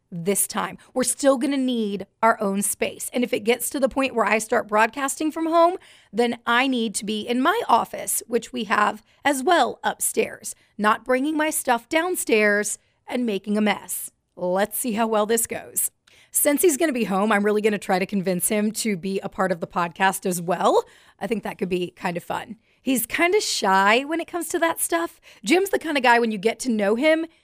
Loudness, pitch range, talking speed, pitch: -22 LUFS, 205-285 Hz, 220 wpm, 230 Hz